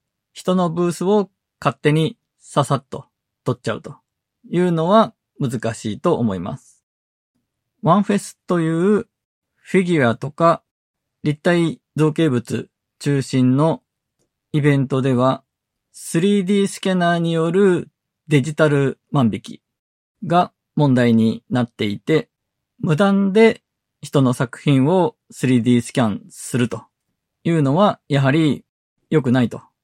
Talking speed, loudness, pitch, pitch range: 225 characters per minute, -19 LUFS, 155 Hz, 130-180 Hz